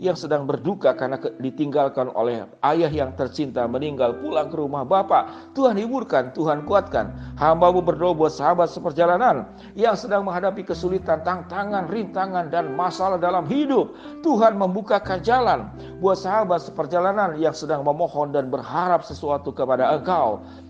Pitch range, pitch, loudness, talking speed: 150-195 Hz, 175 Hz, -22 LUFS, 135 wpm